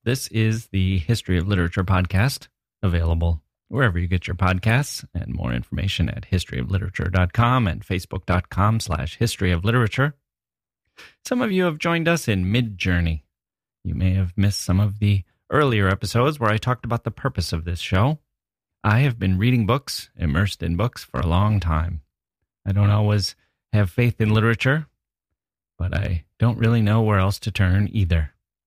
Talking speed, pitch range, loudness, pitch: 165 wpm, 90-115 Hz, -22 LUFS, 100 Hz